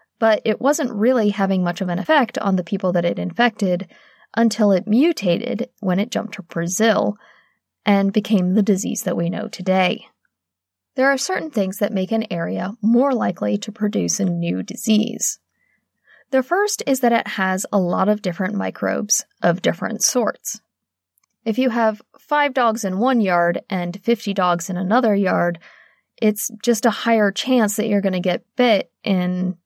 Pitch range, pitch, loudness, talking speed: 185-235 Hz, 210 Hz, -20 LUFS, 175 wpm